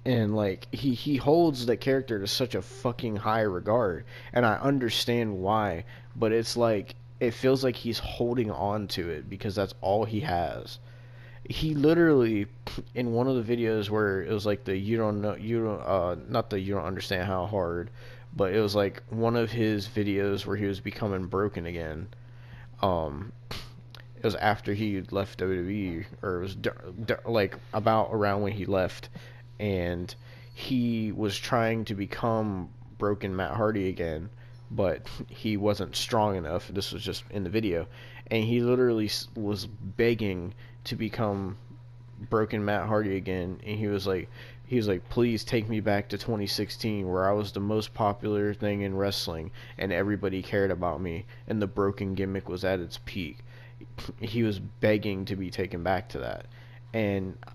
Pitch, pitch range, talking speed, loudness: 110 Hz, 100-120 Hz, 175 wpm, -29 LUFS